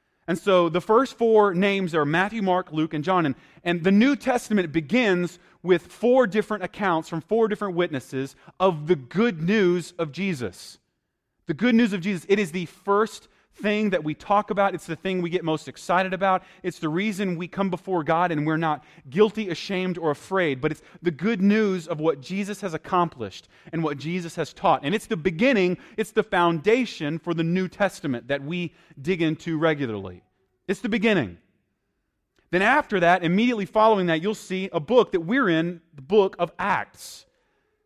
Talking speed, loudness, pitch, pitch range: 190 wpm, -24 LUFS, 180 Hz, 165-205 Hz